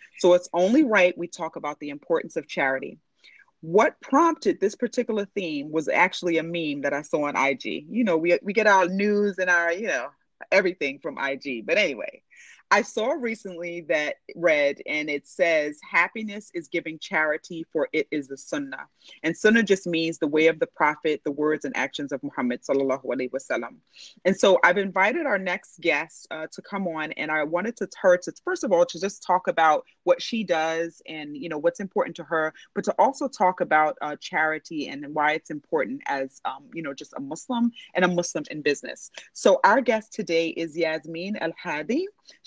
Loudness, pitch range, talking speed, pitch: -24 LUFS, 155-200 Hz, 200 wpm, 170 Hz